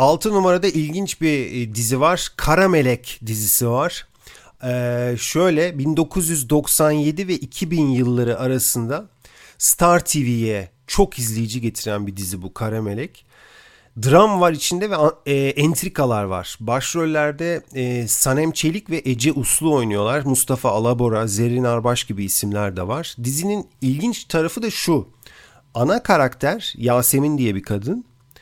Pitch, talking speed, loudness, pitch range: 135 Hz, 125 wpm, -19 LUFS, 120-160 Hz